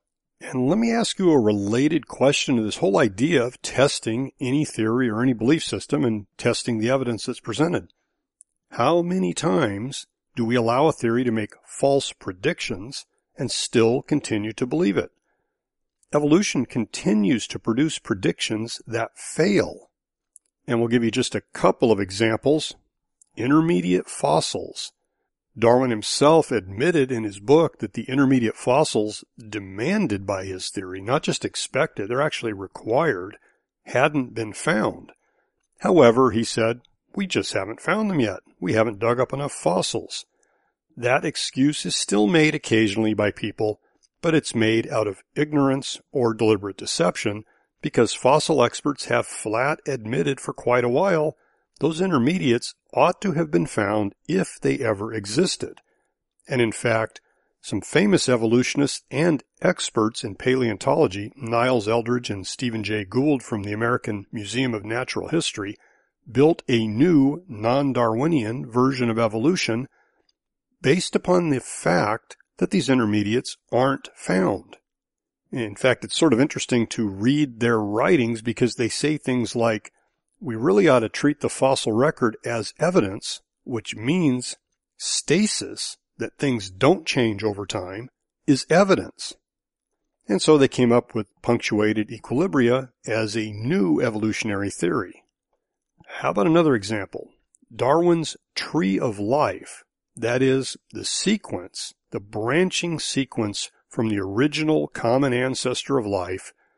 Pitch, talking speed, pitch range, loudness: 120 Hz, 140 wpm, 110-140 Hz, -22 LUFS